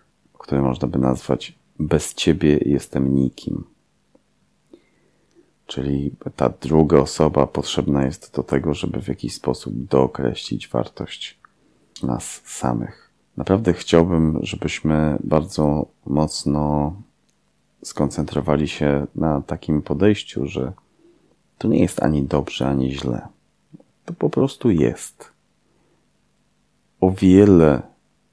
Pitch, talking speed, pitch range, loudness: 75 Hz, 100 wpm, 70-80 Hz, -20 LUFS